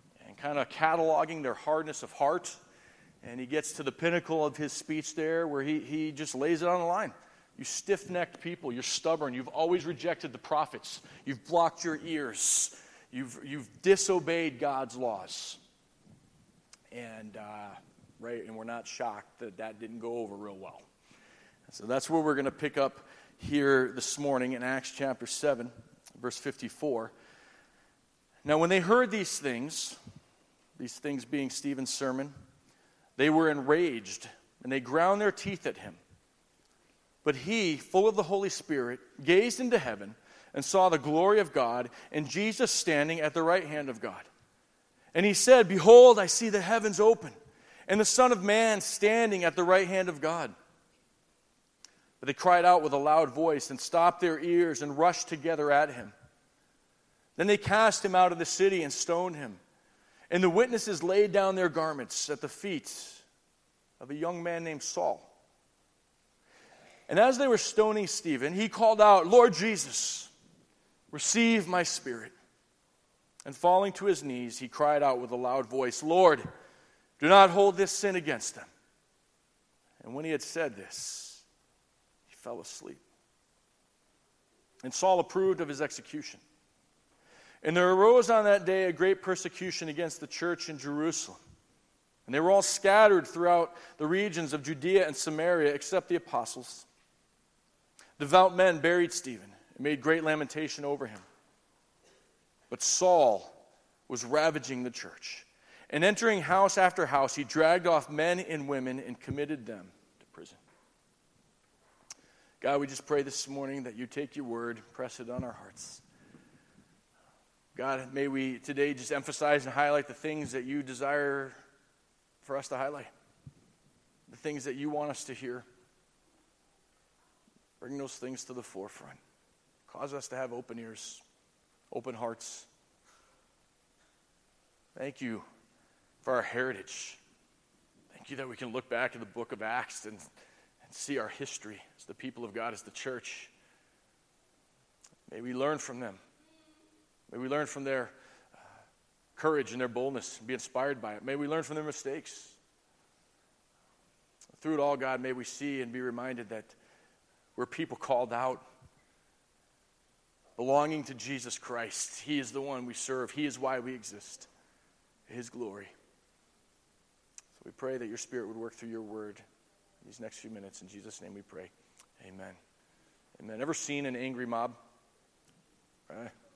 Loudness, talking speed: -29 LUFS, 160 wpm